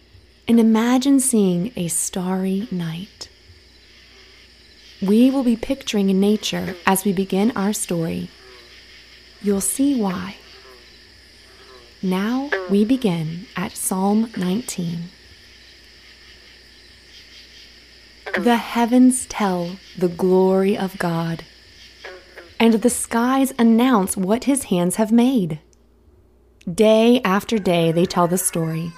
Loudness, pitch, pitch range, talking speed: -19 LUFS, 195 Hz, 175-225 Hz, 100 wpm